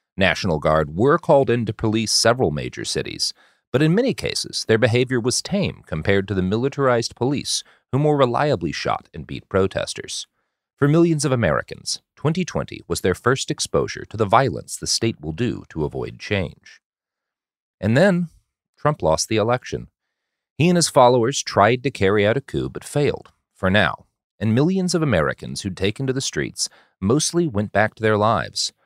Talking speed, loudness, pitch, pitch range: 175 wpm, -20 LUFS, 120 Hz, 105-145 Hz